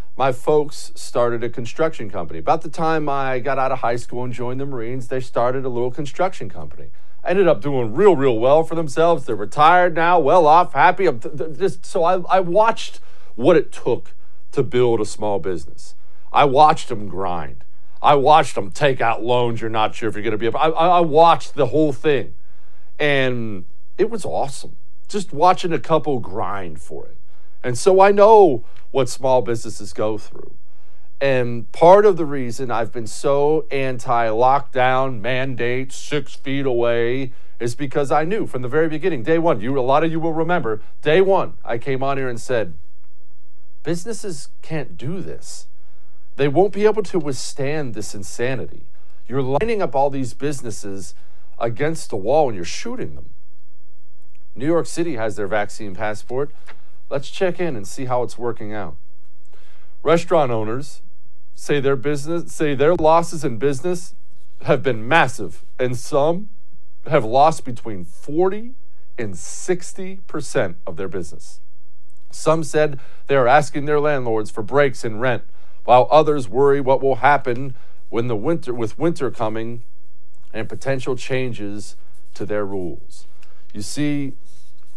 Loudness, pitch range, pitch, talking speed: -19 LUFS, 105-155 Hz, 130 Hz, 165 wpm